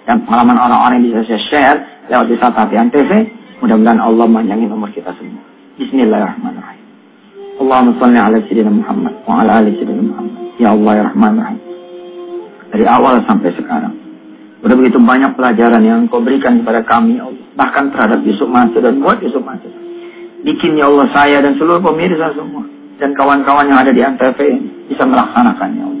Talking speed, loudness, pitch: 170 wpm, -11 LUFS, 175 Hz